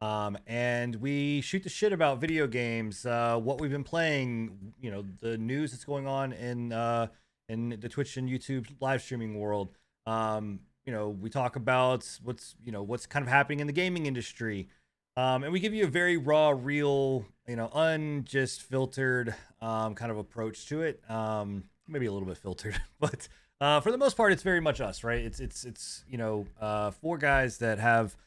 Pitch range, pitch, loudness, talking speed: 110-140 Hz, 120 Hz, -31 LUFS, 200 wpm